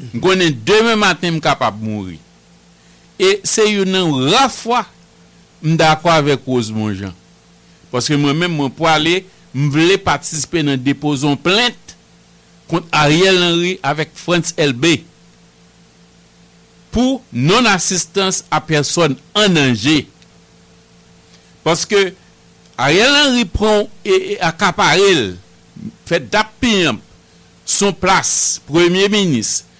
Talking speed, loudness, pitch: 110 wpm, -14 LUFS, 155 Hz